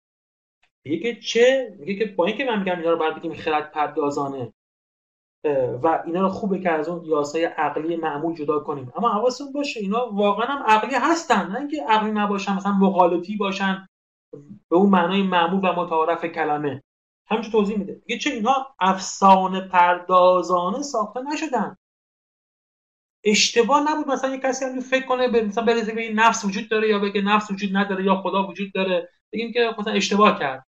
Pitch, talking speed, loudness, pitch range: 200 Hz, 170 wpm, -21 LUFS, 175-235 Hz